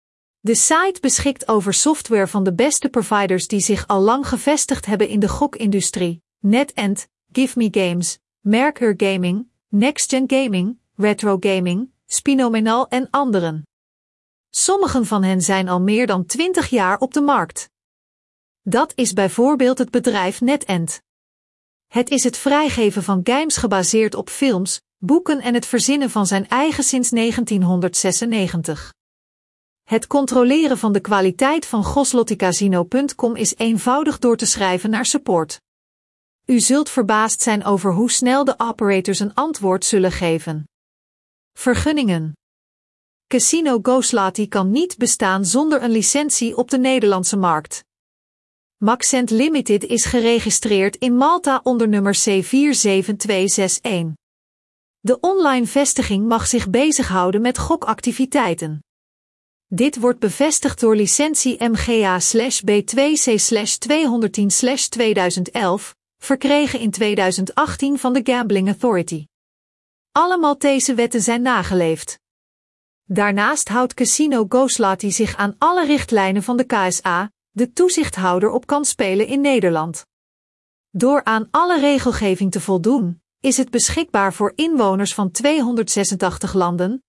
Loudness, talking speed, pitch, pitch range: -17 LUFS, 120 wpm, 225 Hz, 195-260 Hz